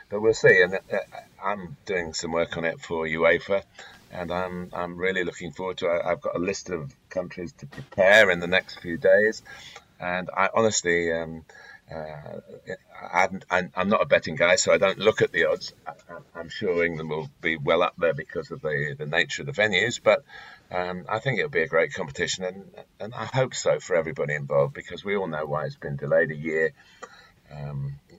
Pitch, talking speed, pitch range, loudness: 85 Hz, 200 wpm, 80-95 Hz, -24 LUFS